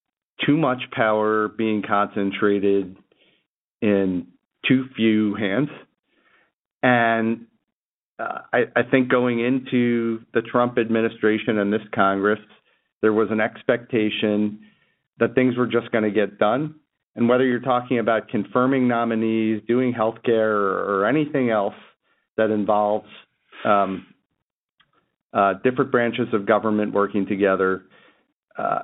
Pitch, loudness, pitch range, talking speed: 110 Hz, -21 LUFS, 105-120 Hz, 125 wpm